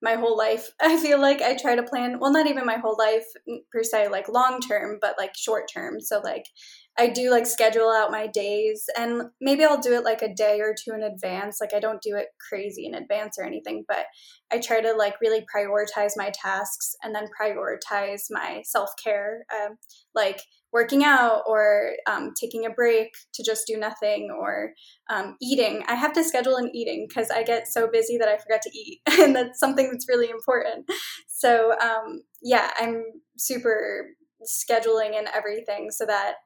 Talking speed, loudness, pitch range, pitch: 195 wpm, -24 LUFS, 215-250 Hz, 225 Hz